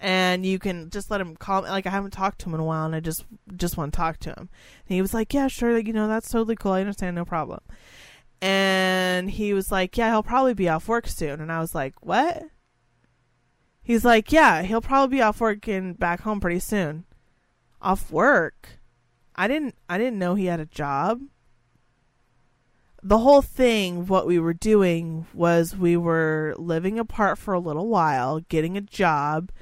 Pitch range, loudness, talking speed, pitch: 160-215 Hz, -23 LUFS, 205 wpm, 185 Hz